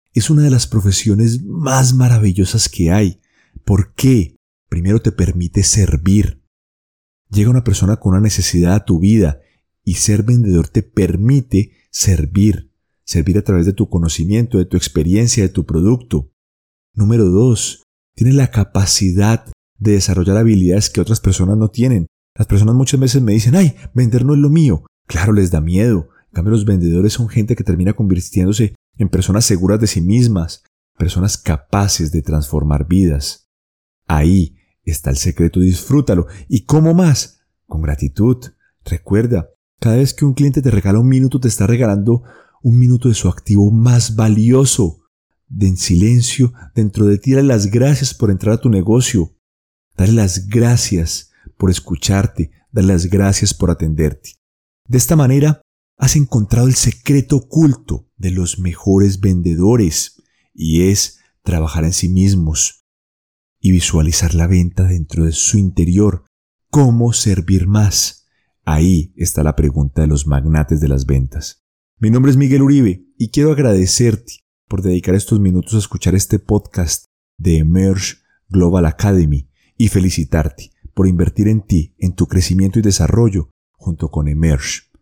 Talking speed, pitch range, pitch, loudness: 155 wpm, 85-115 Hz, 95 Hz, -14 LUFS